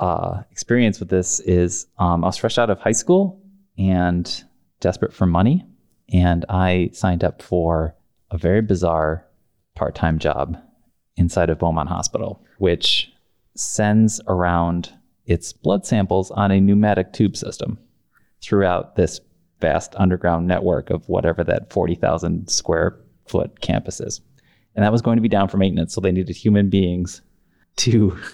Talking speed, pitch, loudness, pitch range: 150 wpm, 95 Hz, -20 LUFS, 85-105 Hz